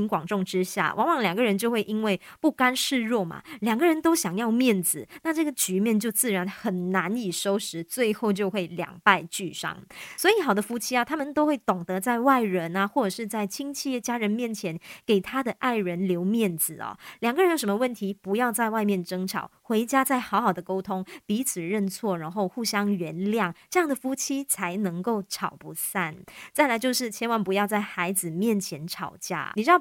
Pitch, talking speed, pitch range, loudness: 210 Hz, 290 characters per minute, 190-245 Hz, -26 LUFS